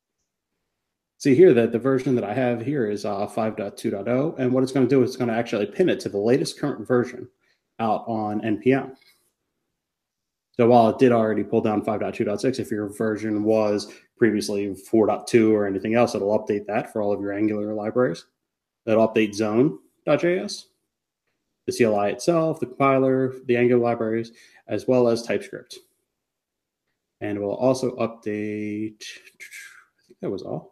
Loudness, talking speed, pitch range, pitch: -22 LUFS, 165 wpm, 105-125 Hz, 115 Hz